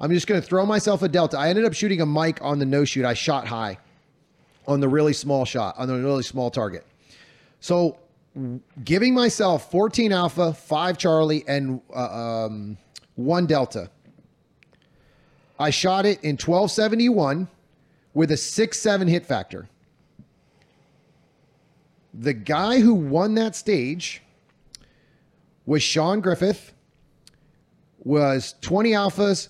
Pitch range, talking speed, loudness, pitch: 140-195 Hz, 130 wpm, -22 LUFS, 160 Hz